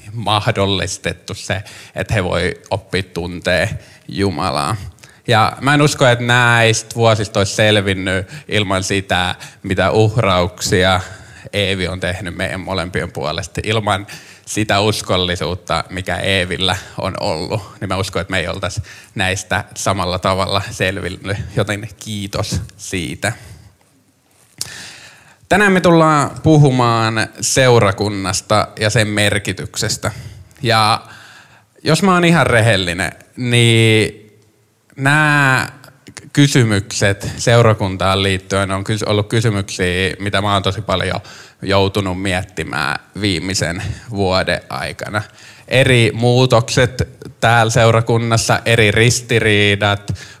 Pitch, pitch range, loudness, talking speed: 105 Hz, 95-115 Hz, -16 LUFS, 100 wpm